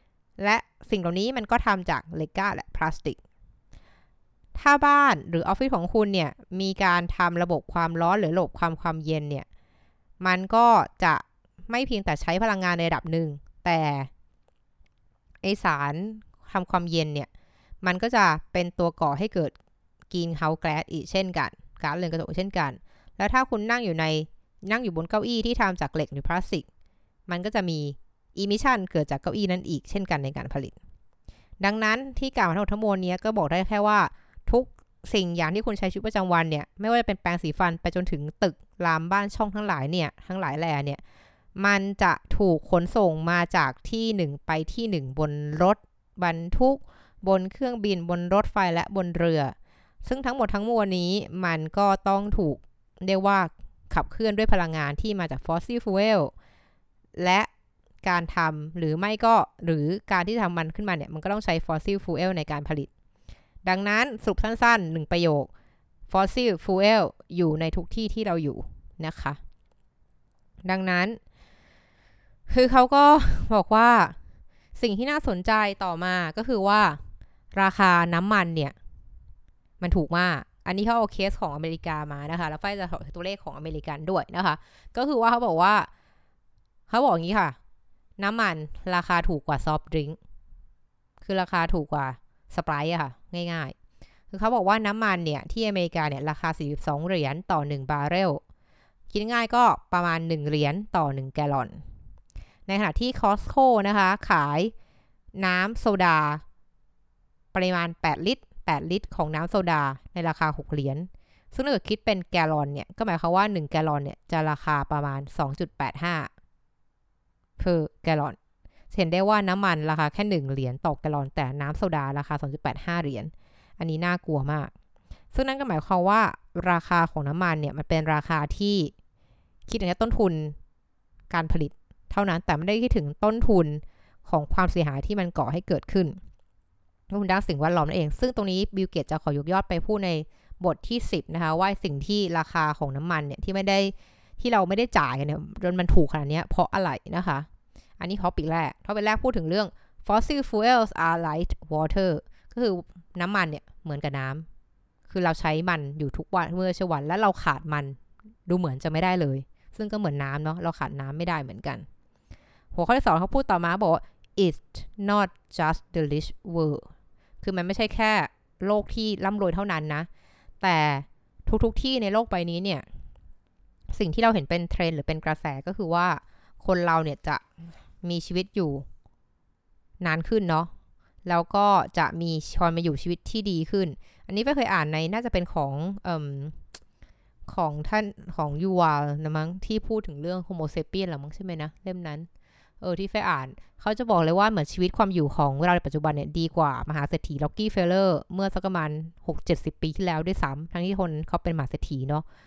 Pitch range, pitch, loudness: 155-200 Hz, 175 Hz, -26 LUFS